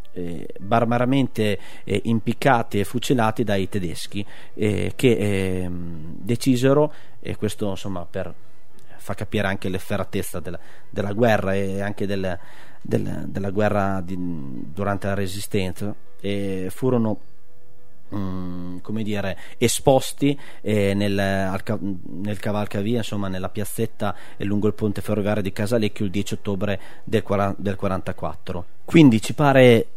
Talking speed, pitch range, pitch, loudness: 130 wpm, 95-110 Hz, 100 Hz, -23 LUFS